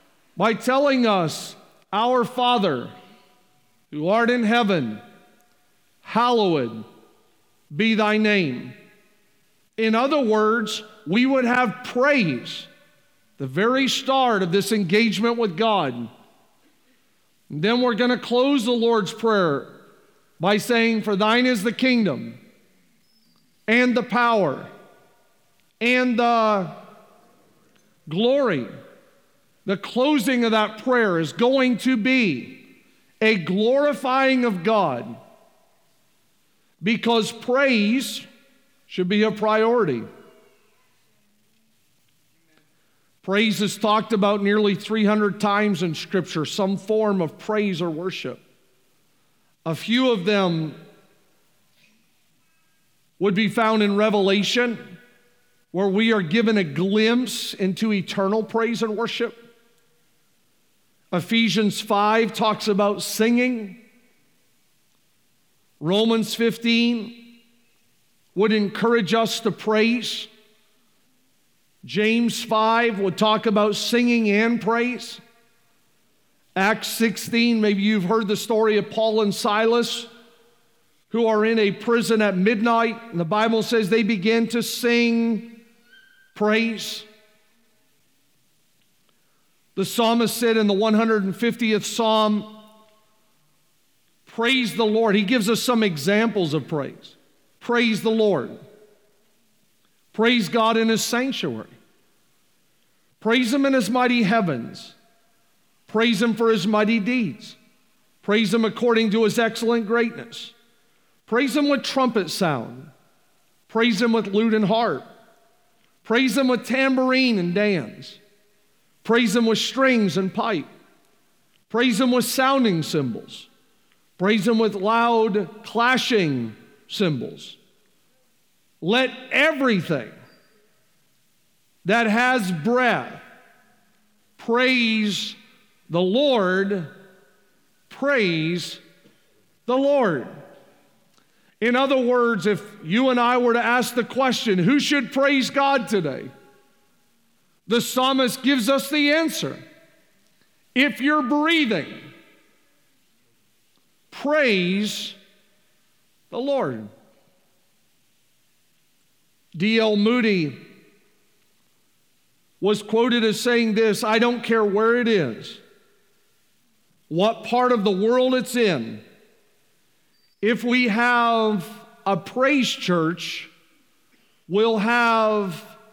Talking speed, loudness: 100 wpm, -21 LUFS